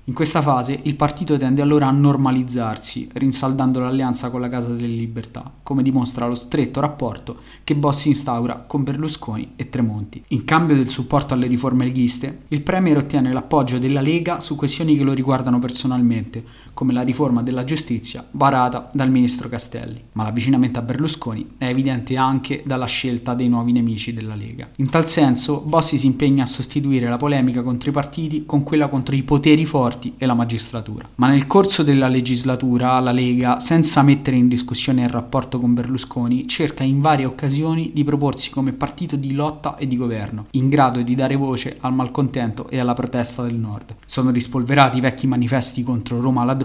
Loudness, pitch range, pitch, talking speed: -19 LUFS, 125-140 Hz, 130 Hz, 180 wpm